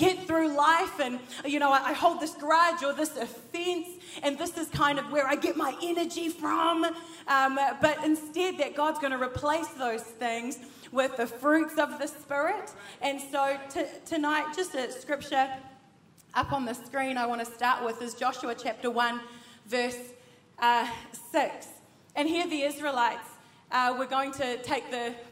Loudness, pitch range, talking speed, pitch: -29 LUFS, 245-310 Hz, 175 wpm, 280 Hz